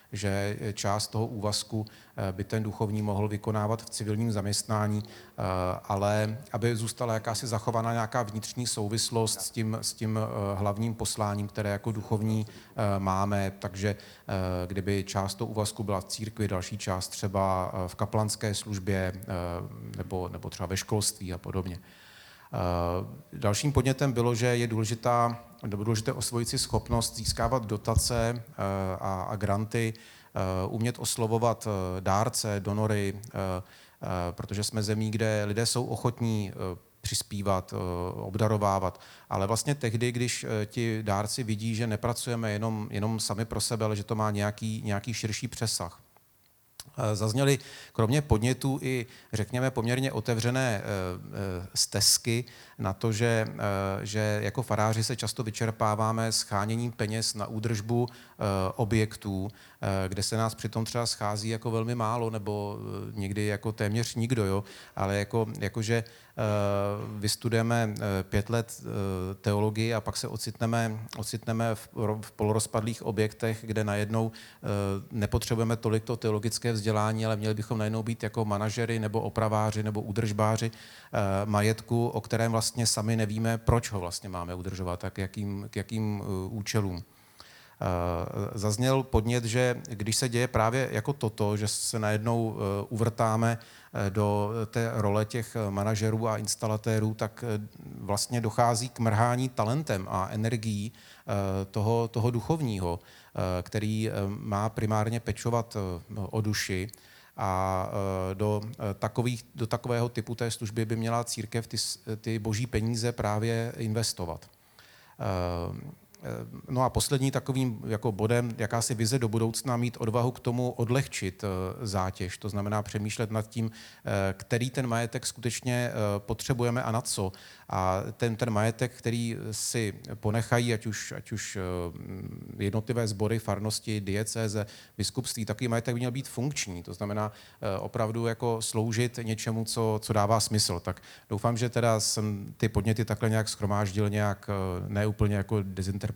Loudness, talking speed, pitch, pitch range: -30 LUFS, 130 wpm, 110 Hz, 100-115 Hz